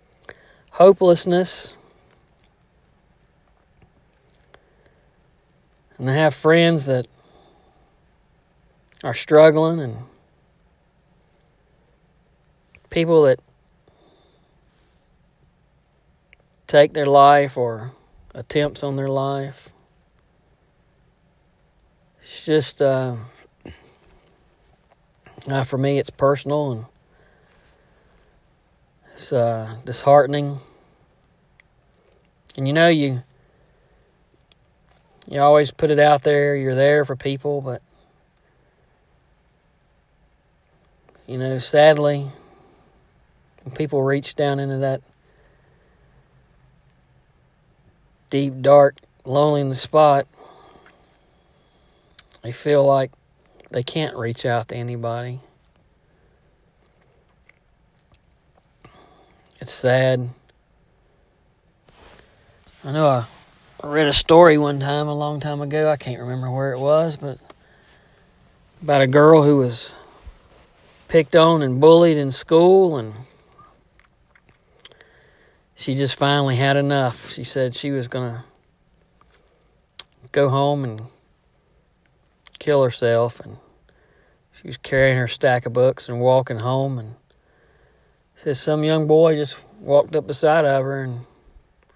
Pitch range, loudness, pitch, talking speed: 130-150 Hz, -18 LUFS, 140 Hz, 90 wpm